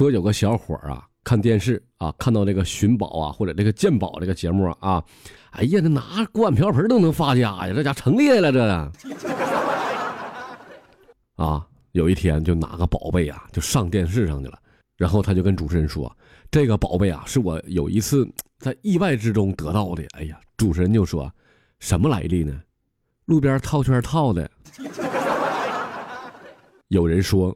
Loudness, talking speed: -21 LUFS, 245 characters per minute